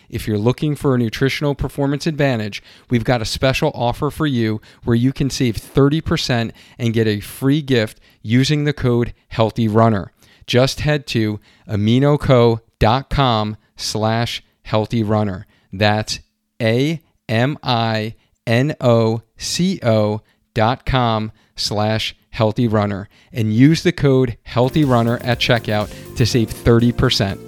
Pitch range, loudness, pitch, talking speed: 110-130 Hz, -18 LUFS, 115 Hz, 110 wpm